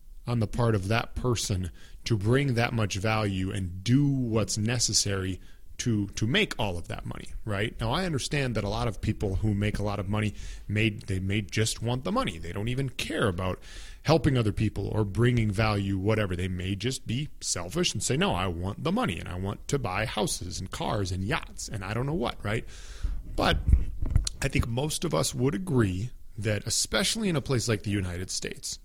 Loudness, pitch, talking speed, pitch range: -28 LUFS, 110 Hz, 210 wpm, 95-120 Hz